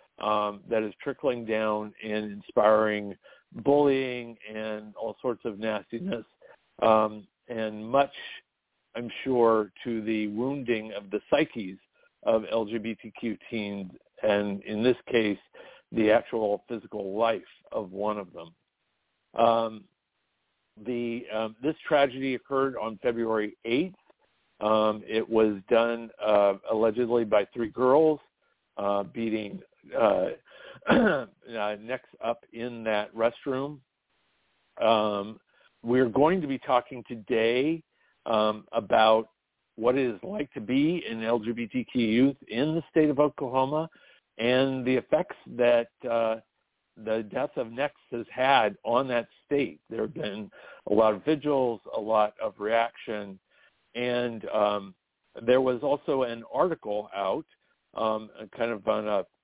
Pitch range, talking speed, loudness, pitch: 110-125 Hz, 130 wpm, -28 LUFS, 115 Hz